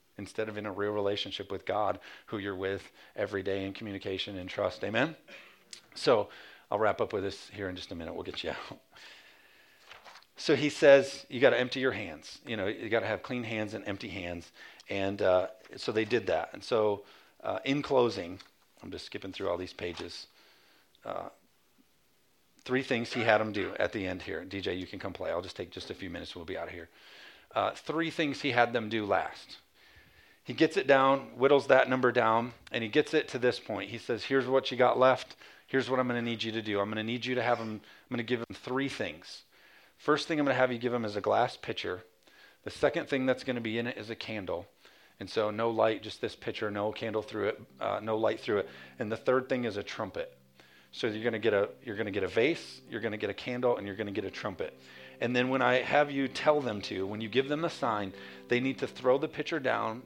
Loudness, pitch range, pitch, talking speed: -31 LUFS, 105-130 Hz, 115 Hz, 250 wpm